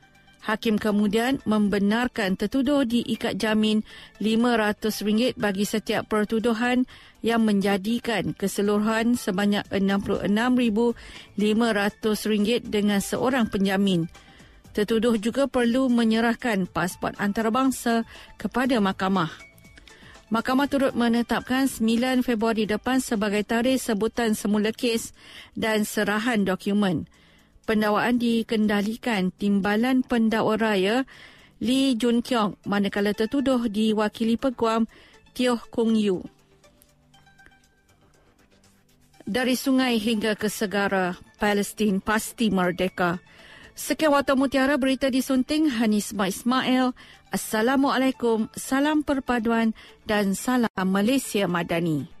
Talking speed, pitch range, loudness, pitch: 90 wpm, 205-245 Hz, -24 LUFS, 220 Hz